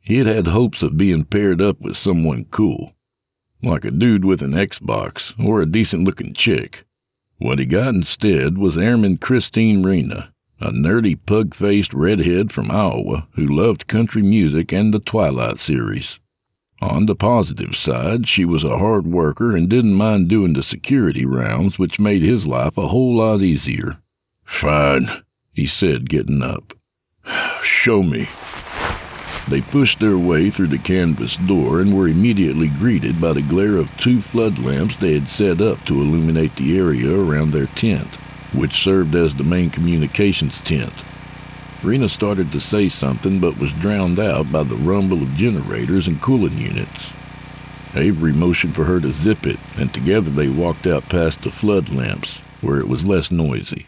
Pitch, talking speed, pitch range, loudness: 95 Hz, 165 wpm, 80-110 Hz, -17 LUFS